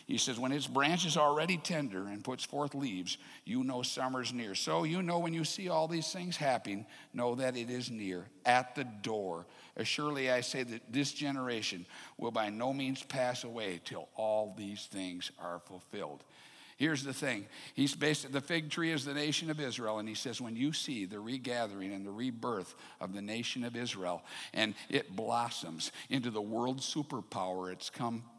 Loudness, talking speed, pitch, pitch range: -36 LUFS, 190 wpm, 125 Hz, 110-140 Hz